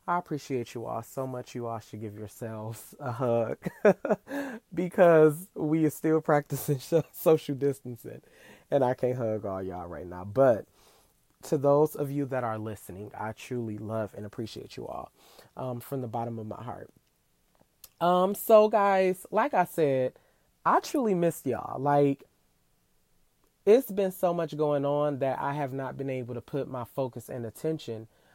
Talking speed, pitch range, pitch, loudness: 165 wpm, 115-155 Hz, 135 Hz, -28 LUFS